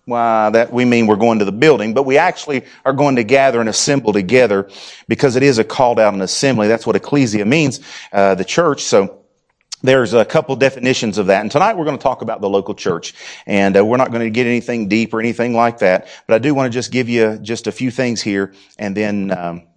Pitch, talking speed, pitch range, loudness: 115 Hz, 260 wpm, 105-130 Hz, -15 LUFS